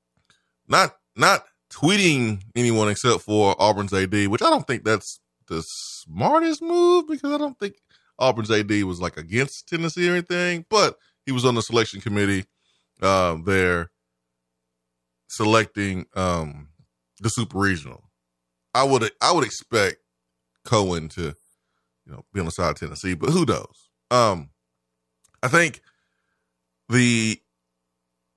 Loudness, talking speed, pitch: -22 LUFS, 135 wpm, 95 Hz